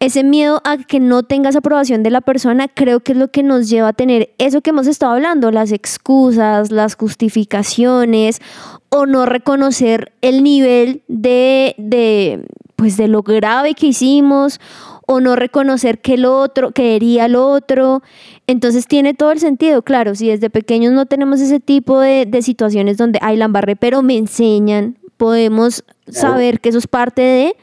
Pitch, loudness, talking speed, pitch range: 250 Hz, -12 LUFS, 170 wpm, 230-275 Hz